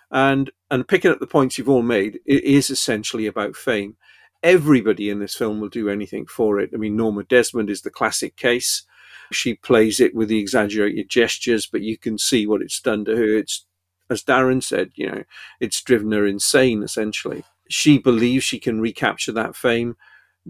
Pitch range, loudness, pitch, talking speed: 105-130 Hz, -20 LUFS, 110 Hz, 190 wpm